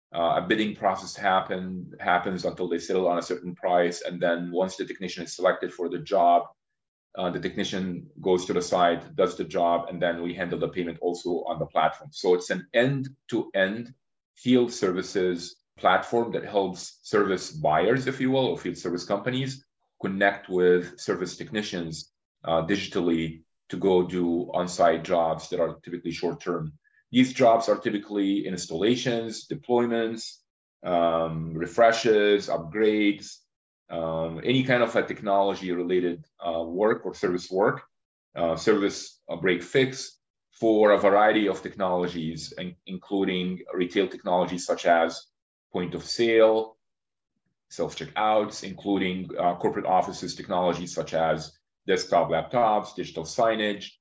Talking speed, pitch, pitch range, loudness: 140 wpm, 95 Hz, 85-110 Hz, -26 LUFS